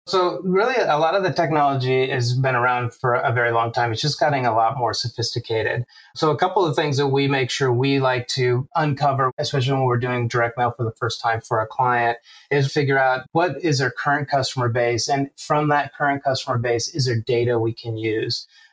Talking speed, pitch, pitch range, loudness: 220 wpm, 130 Hz, 120-145 Hz, -21 LUFS